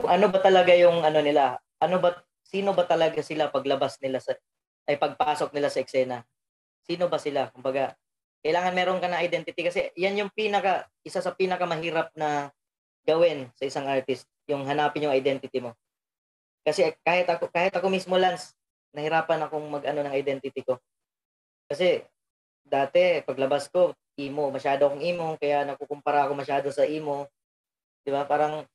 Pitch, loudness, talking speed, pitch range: 150 Hz, -26 LUFS, 160 wpm, 140-175 Hz